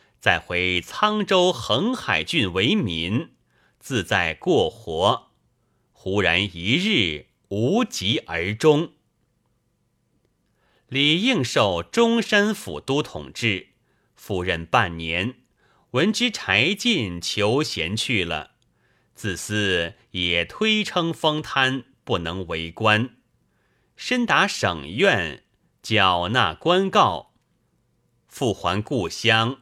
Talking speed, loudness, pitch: 130 characters per minute, -22 LUFS, 120 Hz